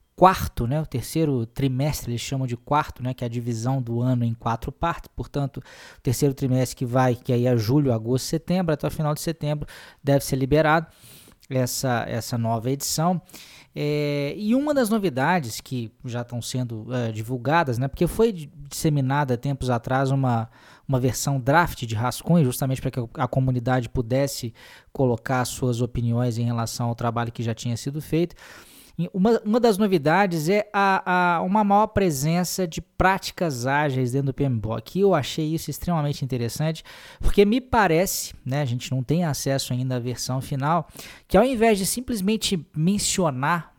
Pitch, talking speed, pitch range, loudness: 140 Hz, 175 wpm, 125-170 Hz, -24 LUFS